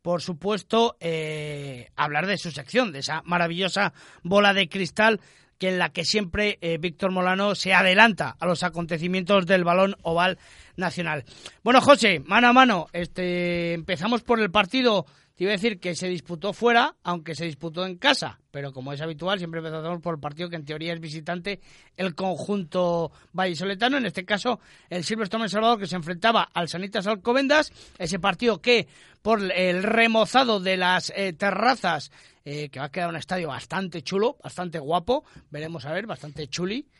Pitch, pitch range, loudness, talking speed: 185 Hz, 170-210 Hz, -24 LUFS, 175 wpm